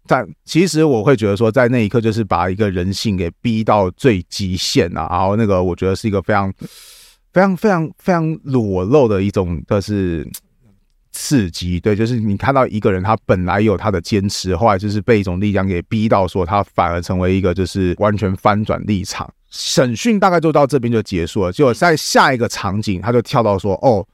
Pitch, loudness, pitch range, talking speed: 105 Hz, -16 LUFS, 95-115 Hz, 305 characters per minute